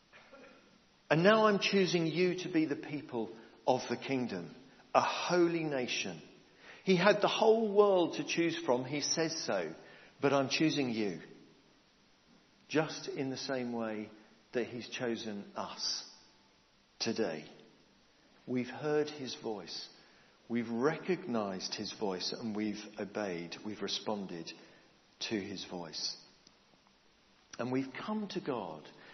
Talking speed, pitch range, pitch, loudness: 125 wpm, 115-170 Hz, 135 Hz, -34 LUFS